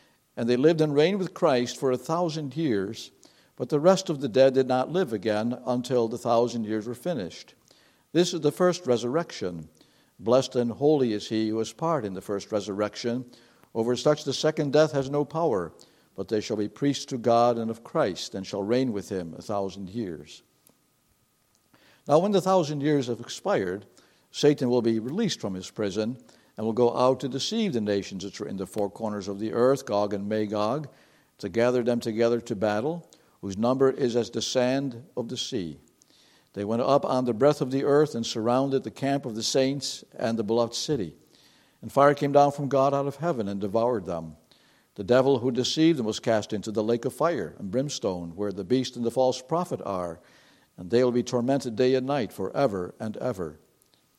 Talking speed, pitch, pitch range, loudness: 205 wpm, 125 Hz, 110-140 Hz, -26 LUFS